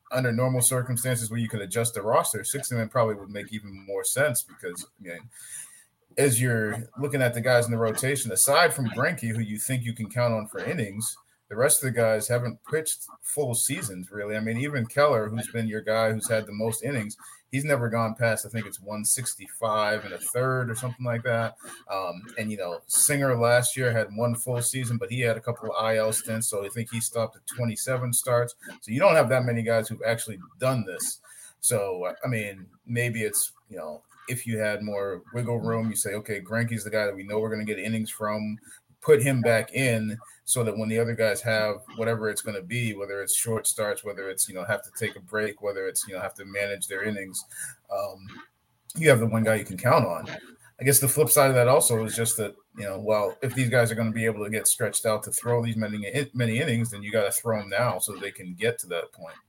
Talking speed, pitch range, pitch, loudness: 245 wpm, 110-125 Hz, 115 Hz, -26 LUFS